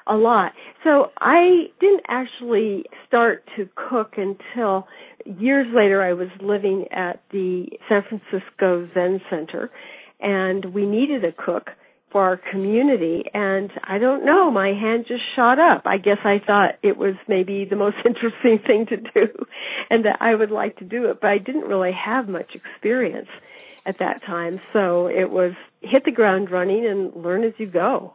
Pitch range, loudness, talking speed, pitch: 190-235 Hz, -20 LUFS, 175 wpm, 205 Hz